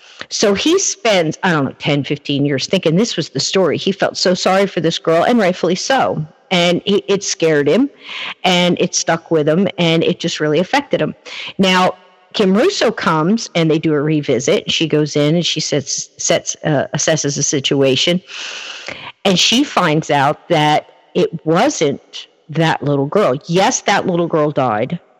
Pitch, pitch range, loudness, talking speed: 170 Hz, 155-195 Hz, -15 LUFS, 180 wpm